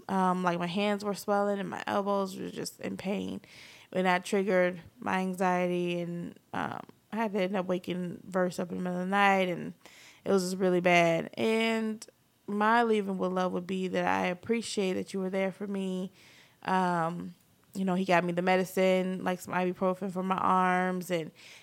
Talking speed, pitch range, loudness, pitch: 195 wpm, 180-200 Hz, -30 LUFS, 185 Hz